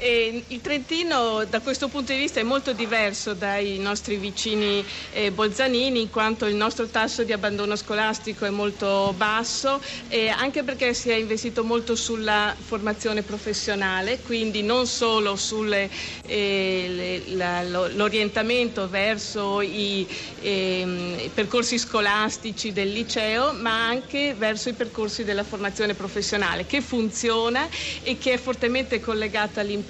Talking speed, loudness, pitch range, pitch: 130 wpm, -24 LUFS, 205-235 Hz, 220 Hz